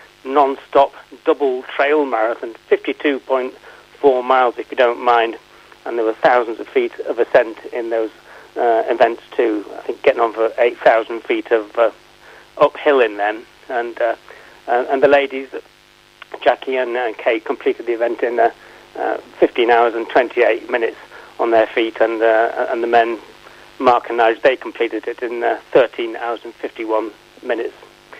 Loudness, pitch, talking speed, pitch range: -17 LUFS, 120 Hz, 165 wpm, 115-140 Hz